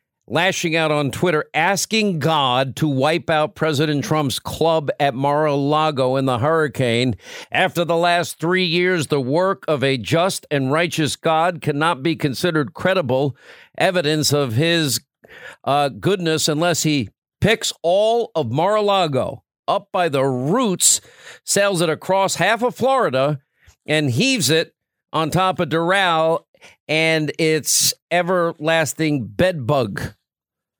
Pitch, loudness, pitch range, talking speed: 160 Hz, -18 LUFS, 145-175 Hz, 135 wpm